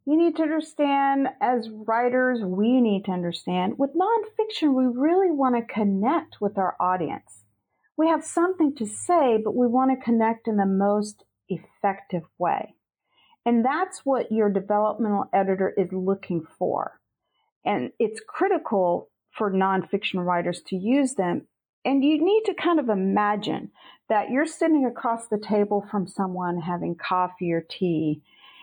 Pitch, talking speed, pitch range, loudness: 220 Hz, 150 wpm, 190-285 Hz, -24 LUFS